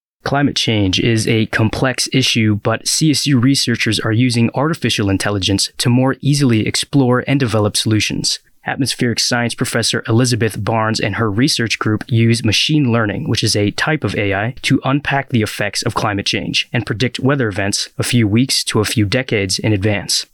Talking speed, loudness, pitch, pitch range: 170 wpm, -15 LUFS, 115 Hz, 110-130 Hz